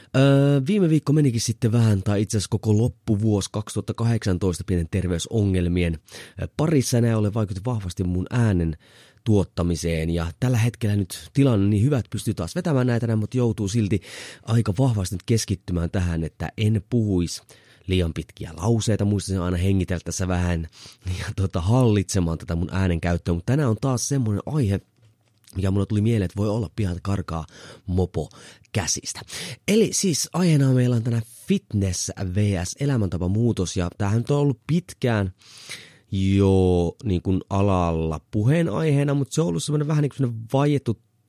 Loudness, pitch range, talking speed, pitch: -23 LUFS, 95-120 Hz, 150 wpm, 105 Hz